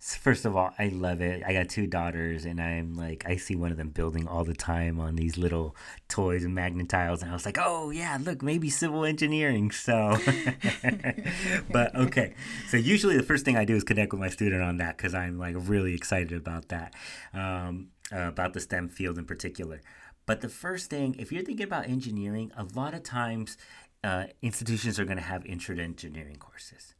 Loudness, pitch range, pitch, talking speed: -30 LUFS, 85-120 Hz, 95 Hz, 205 wpm